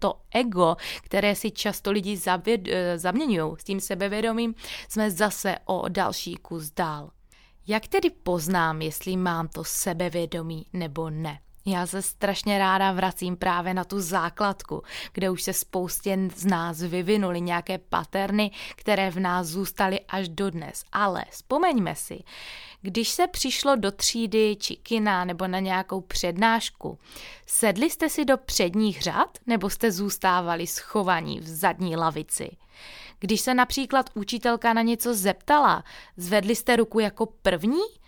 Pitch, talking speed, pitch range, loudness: 195 Hz, 140 wpm, 180-220 Hz, -25 LUFS